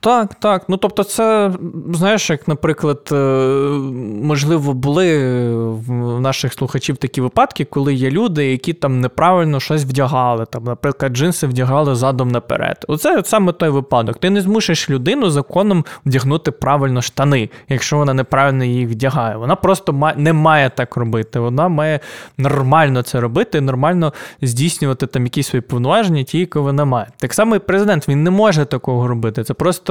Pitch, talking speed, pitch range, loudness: 140 Hz, 160 wpm, 130-165 Hz, -16 LUFS